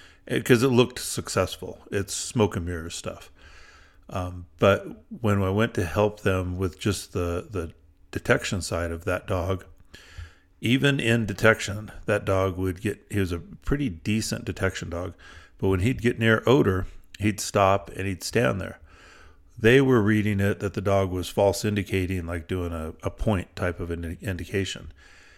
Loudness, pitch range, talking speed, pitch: -25 LUFS, 90-105 Hz, 170 wpm, 95 Hz